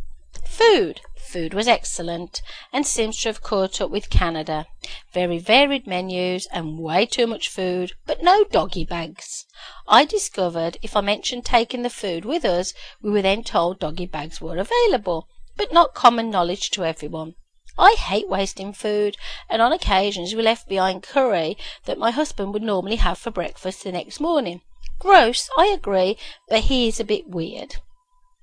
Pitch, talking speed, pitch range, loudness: 205 Hz, 165 wpm, 180-250 Hz, -21 LUFS